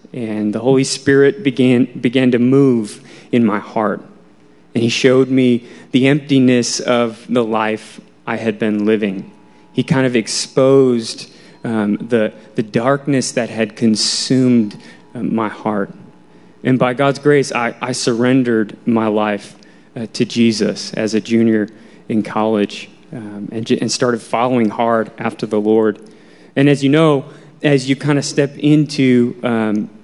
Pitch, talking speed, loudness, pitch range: 120 Hz, 150 wpm, -16 LUFS, 110-135 Hz